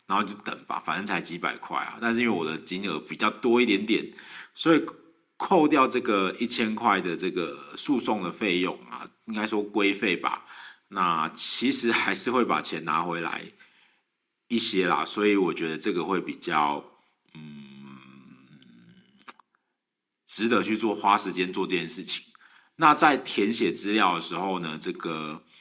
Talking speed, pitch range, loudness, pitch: 230 characters per minute, 85-115 Hz, -24 LUFS, 100 Hz